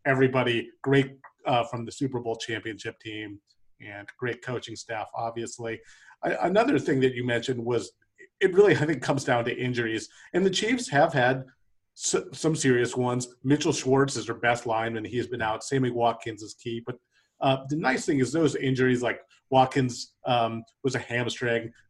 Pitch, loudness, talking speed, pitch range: 125 Hz, -26 LUFS, 180 wpm, 115-135 Hz